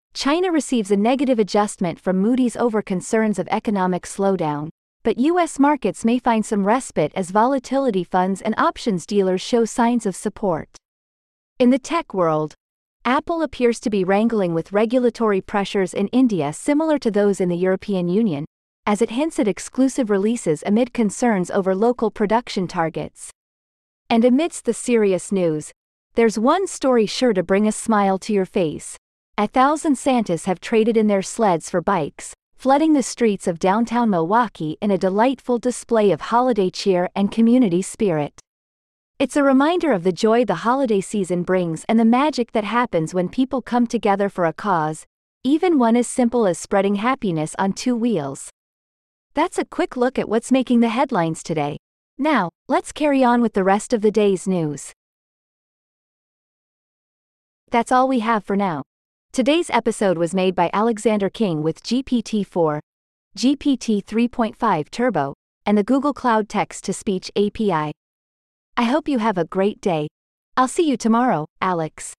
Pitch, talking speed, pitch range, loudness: 220 Hz, 165 wpm, 185-245 Hz, -20 LUFS